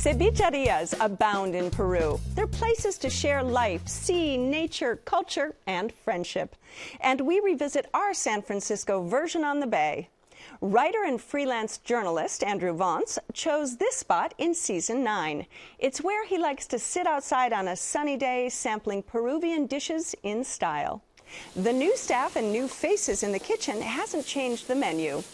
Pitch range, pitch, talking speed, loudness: 220-325 Hz, 270 Hz, 155 wpm, -28 LUFS